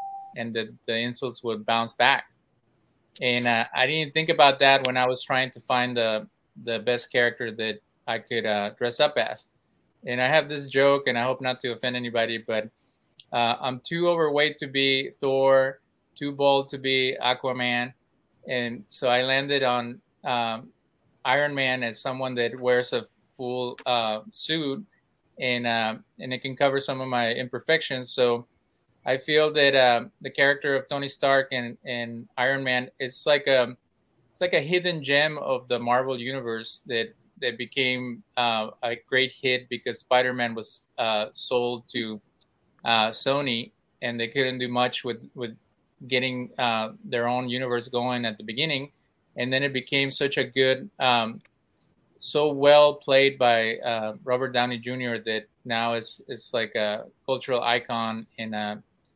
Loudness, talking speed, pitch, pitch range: -25 LUFS, 165 wpm, 125 Hz, 120-135 Hz